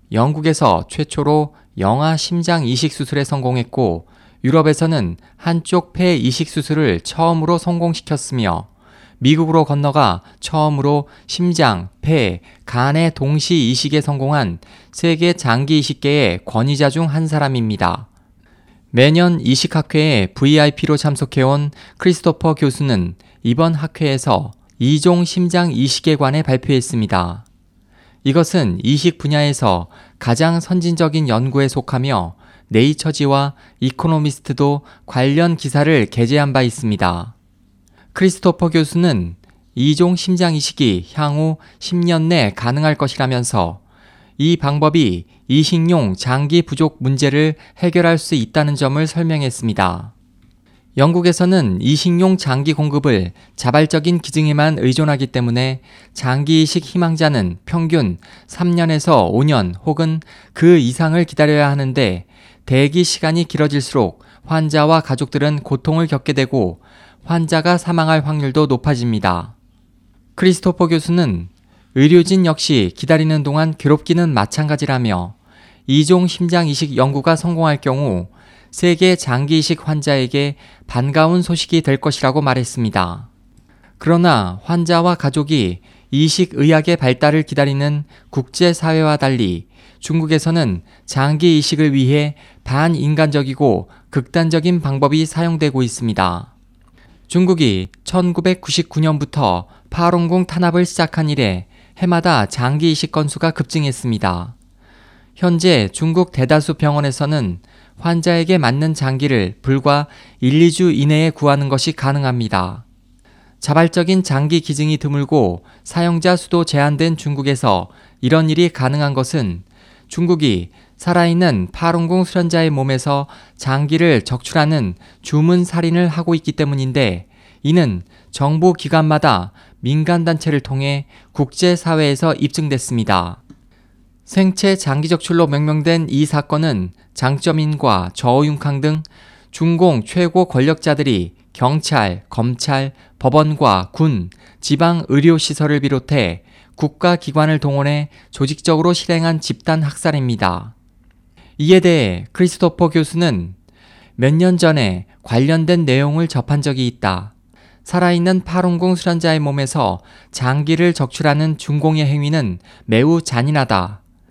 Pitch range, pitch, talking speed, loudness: 120-165 Hz, 145 Hz, 275 characters per minute, -16 LUFS